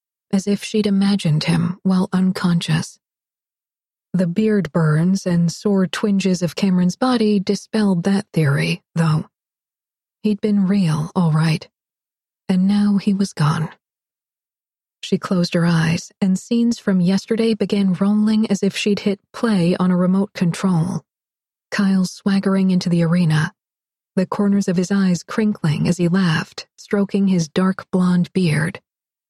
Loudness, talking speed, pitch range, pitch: -19 LUFS, 140 wpm, 175-200 Hz, 190 Hz